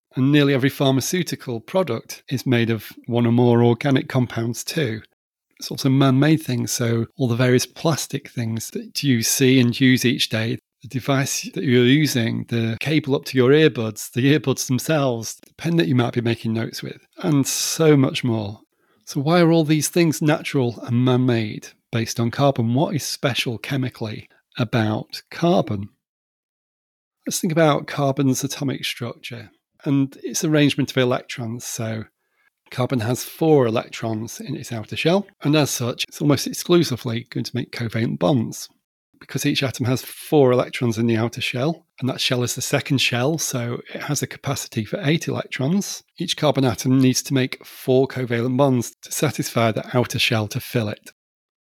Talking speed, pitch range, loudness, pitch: 175 wpm, 120-145 Hz, -21 LUFS, 130 Hz